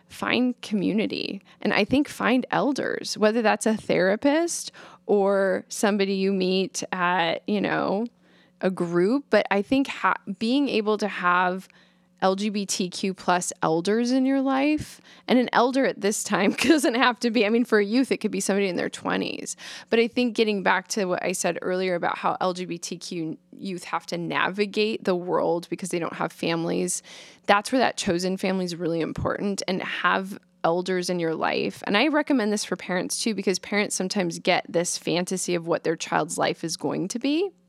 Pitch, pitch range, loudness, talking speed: 200 Hz, 180-230 Hz, -24 LUFS, 185 wpm